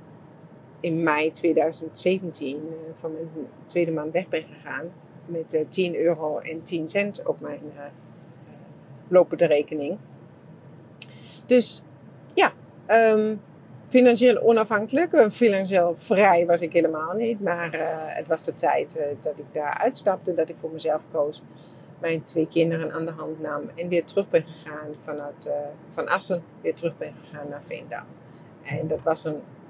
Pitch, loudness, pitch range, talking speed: 160 Hz, -24 LUFS, 155-175 Hz, 155 wpm